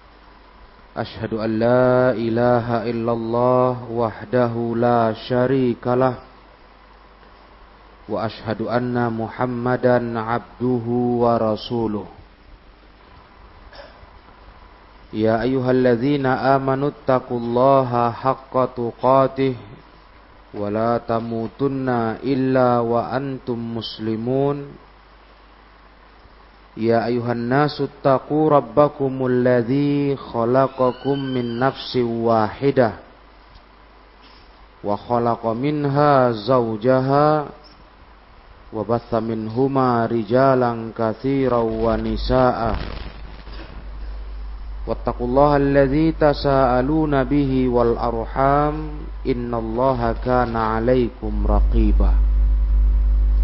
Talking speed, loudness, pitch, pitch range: 65 wpm, -20 LUFS, 120 Hz, 110-130 Hz